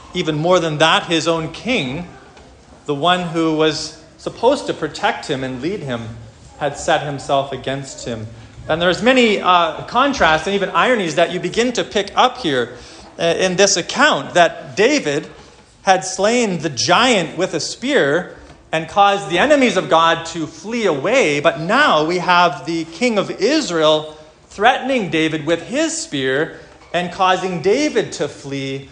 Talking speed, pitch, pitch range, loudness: 160 wpm, 170 Hz, 155-200 Hz, -17 LUFS